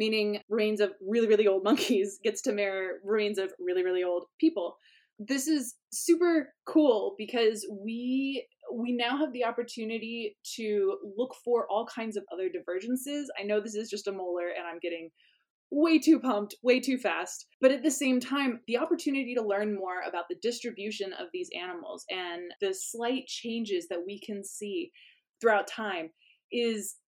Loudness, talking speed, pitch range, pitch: -30 LUFS, 175 wpm, 200-270 Hz, 225 Hz